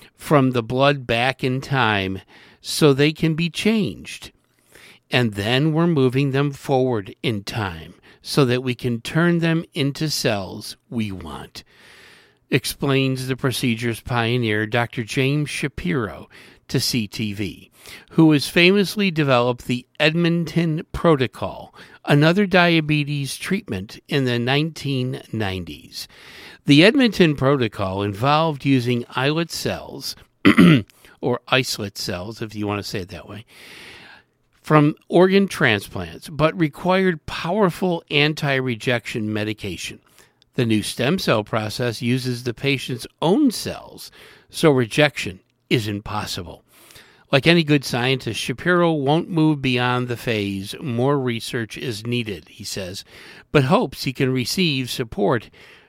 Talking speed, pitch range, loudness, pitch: 120 wpm, 115-155 Hz, -20 LUFS, 130 Hz